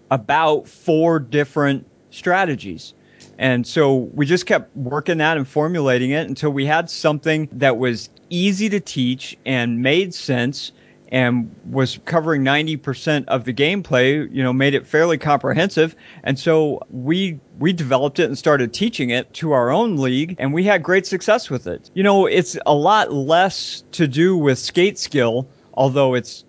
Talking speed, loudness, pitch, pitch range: 165 wpm, -18 LUFS, 145 Hz, 130-165 Hz